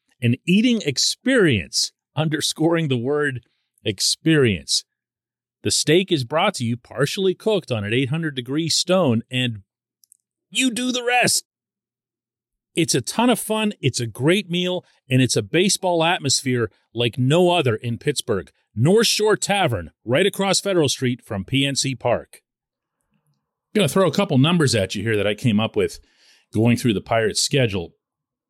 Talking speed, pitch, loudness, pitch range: 155 wpm, 145 Hz, -20 LUFS, 120-180 Hz